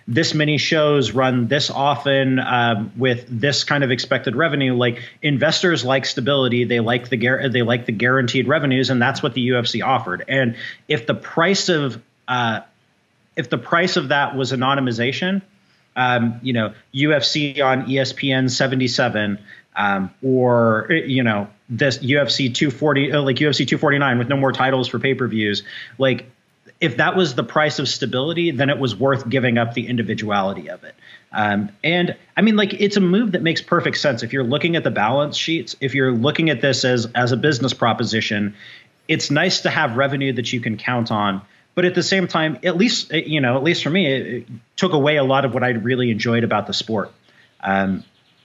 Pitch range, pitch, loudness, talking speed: 120-150 Hz, 135 Hz, -19 LUFS, 195 wpm